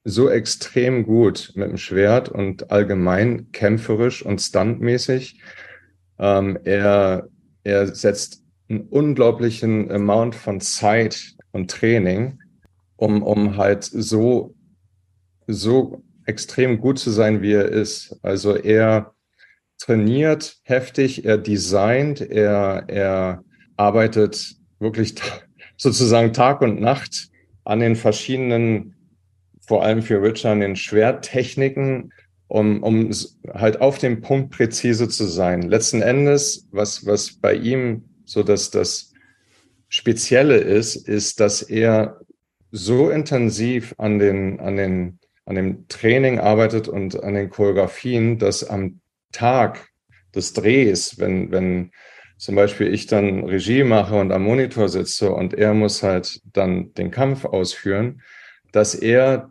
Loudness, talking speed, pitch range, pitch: -19 LUFS, 125 wpm, 100-120 Hz, 110 Hz